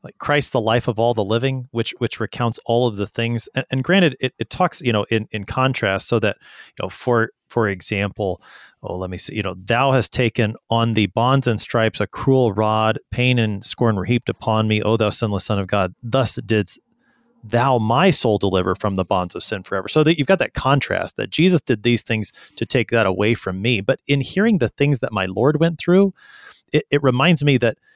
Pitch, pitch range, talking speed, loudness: 120 Hz, 110-135 Hz, 230 wpm, -19 LUFS